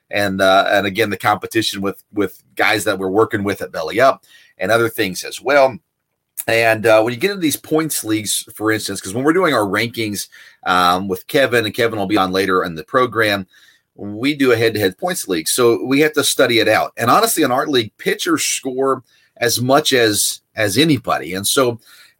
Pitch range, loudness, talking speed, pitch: 100-130 Hz, -16 LUFS, 215 wpm, 110 Hz